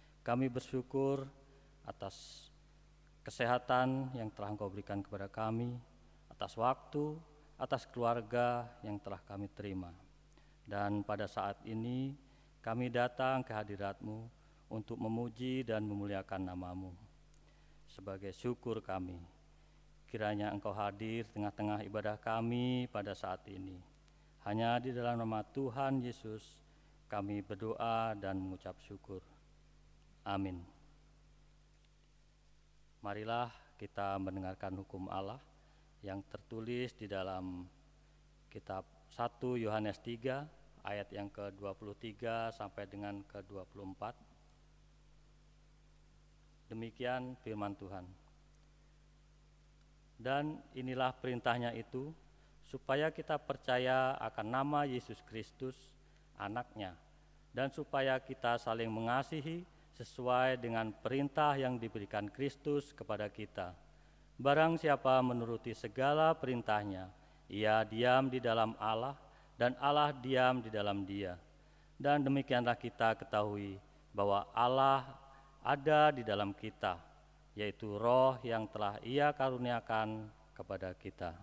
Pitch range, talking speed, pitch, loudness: 100-130 Hz, 100 wpm, 115 Hz, -38 LUFS